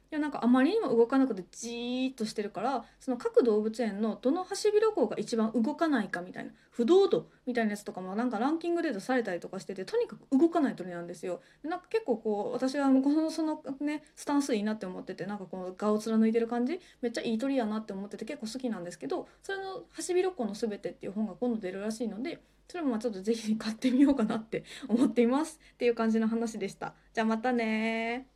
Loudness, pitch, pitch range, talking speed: -31 LUFS, 235 Hz, 220-270 Hz, 490 characters per minute